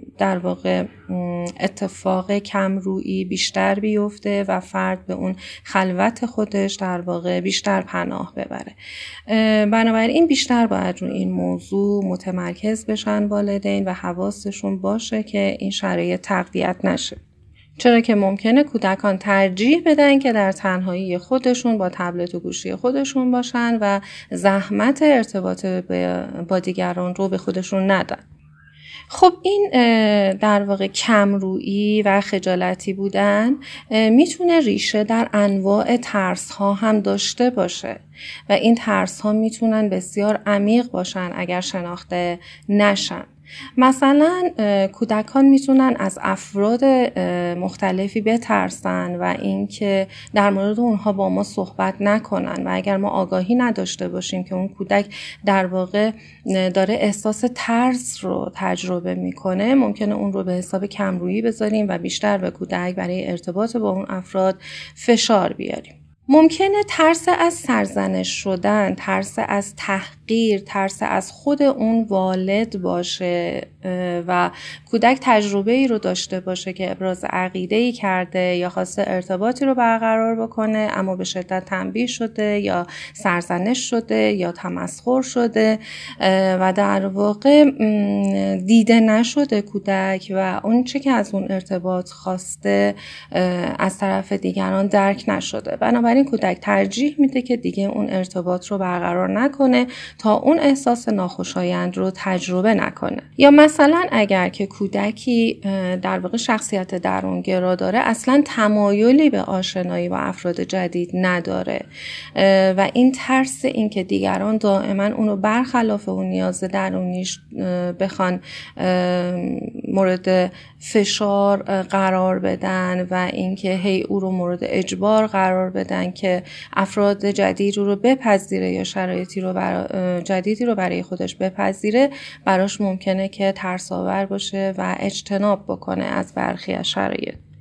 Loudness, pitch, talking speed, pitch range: -19 LUFS, 195 Hz, 125 wpm, 185-220 Hz